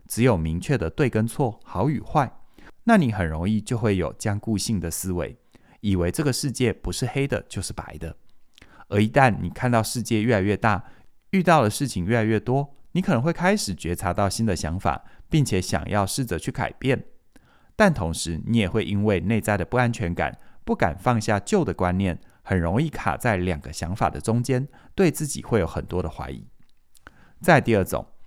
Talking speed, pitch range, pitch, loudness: 280 characters per minute, 90-125 Hz, 105 Hz, -24 LUFS